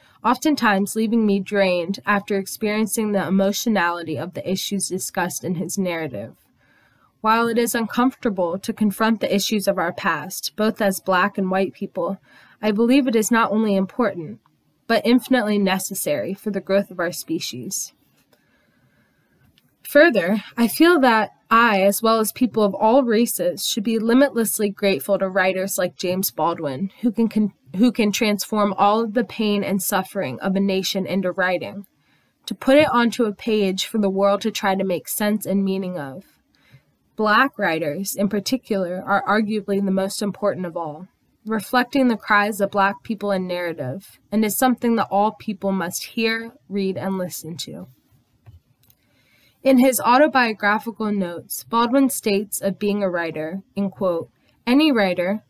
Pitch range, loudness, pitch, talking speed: 185-225 Hz, -20 LUFS, 200 Hz, 160 wpm